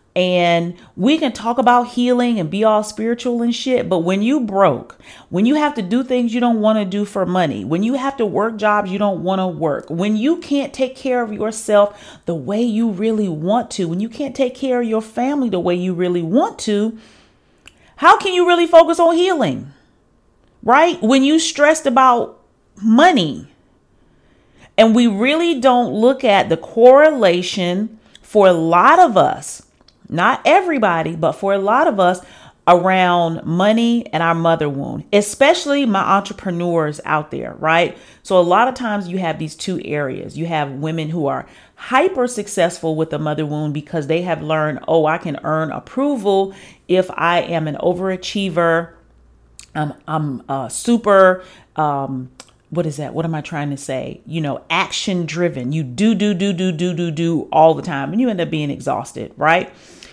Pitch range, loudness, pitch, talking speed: 165-235 Hz, -16 LUFS, 195 Hz, 185 wpm